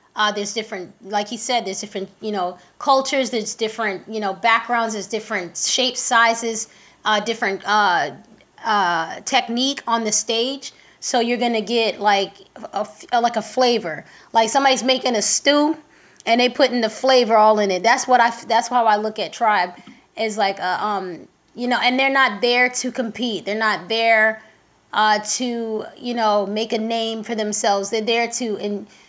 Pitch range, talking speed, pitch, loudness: 210-245 Hz, 185 wpm, 225 Hz, -19 LUFS